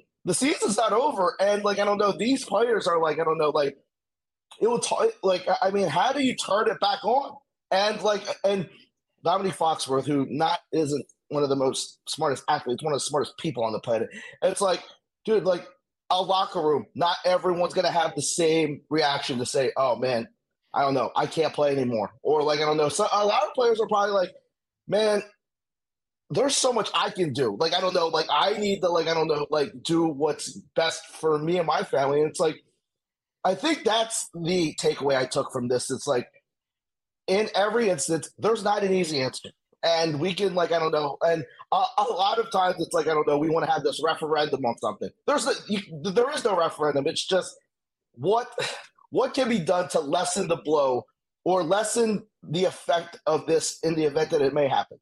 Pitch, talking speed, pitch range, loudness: 175 Hz, 215 wpm, 155-205 Hz, -25 LUFS